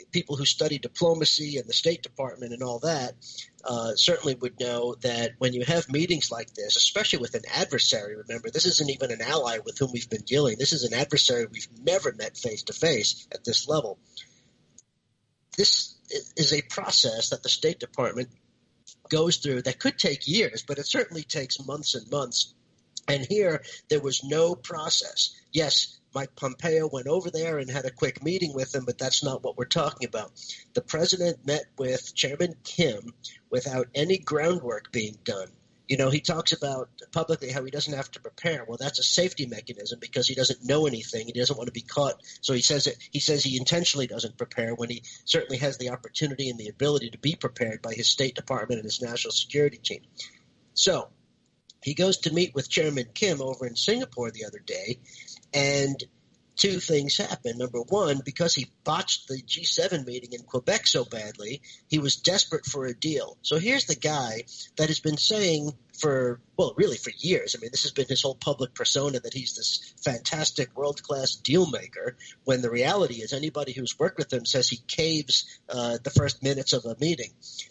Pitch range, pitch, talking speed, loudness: 125-155 Hz, 135 Hz, 195 wpm, -26 LUFS